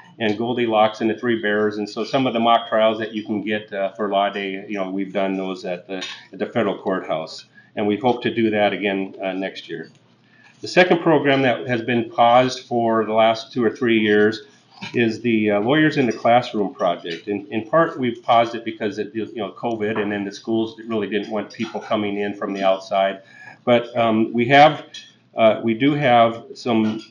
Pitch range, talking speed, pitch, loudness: 105-120 Hz, 220 wpm, 110 Hz, -20 LUFS